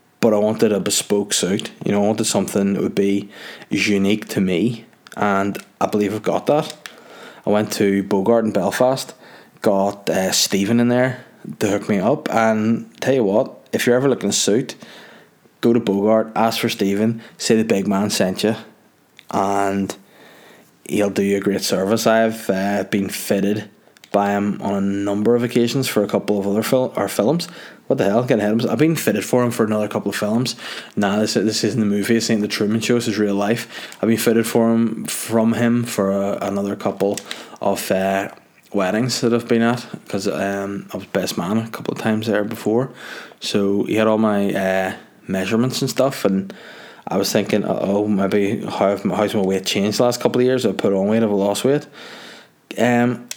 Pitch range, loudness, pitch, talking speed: 100-115 Hz, -19 LUFS, 105 Hz, 205 wpm